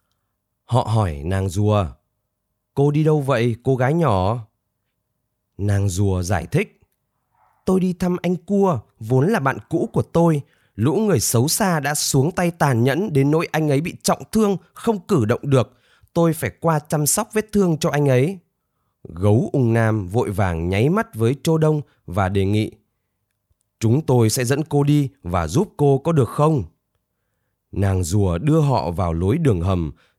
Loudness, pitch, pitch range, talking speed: -20 LUFS, 125 Hz, 105-155 Hz, 175 wpm